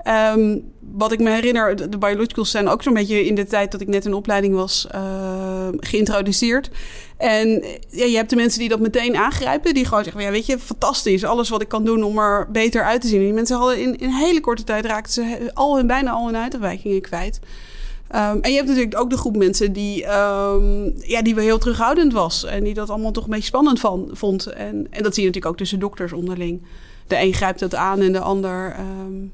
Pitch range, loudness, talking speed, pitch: 195-235 Hz, -19 LUFS, 235 wpm, 210 Hz